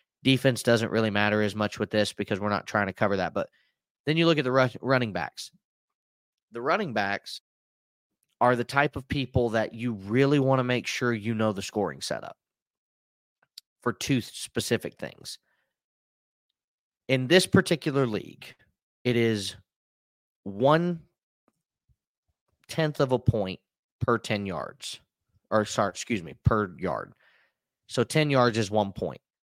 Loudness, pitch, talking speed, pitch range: -27 LUFS, 115 Hz, 150 wpm, 105-130 Hz